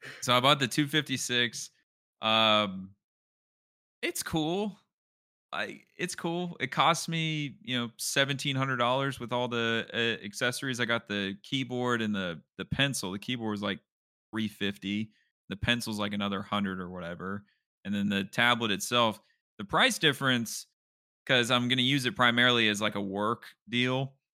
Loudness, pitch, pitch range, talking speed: -29 LUFS, 120 Hz, 105-135 Hz, 160 wpm